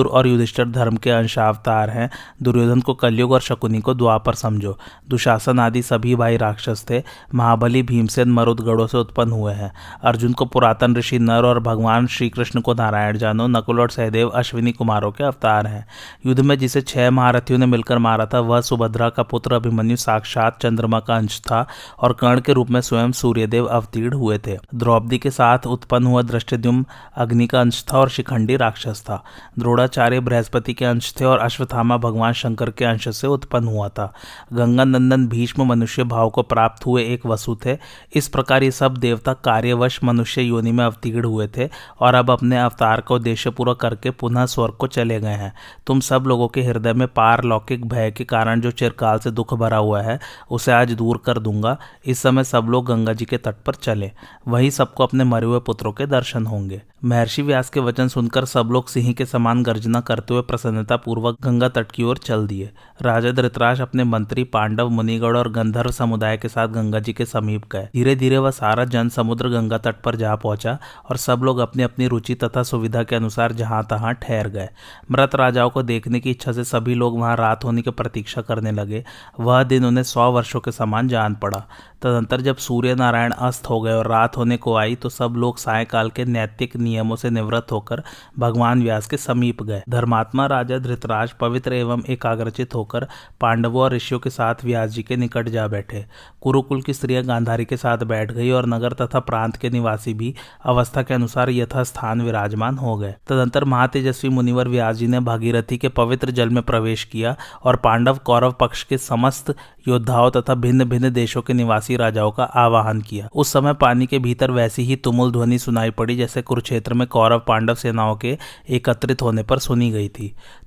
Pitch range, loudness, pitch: 115-125 Hz, -19 LUFS, 120 Hz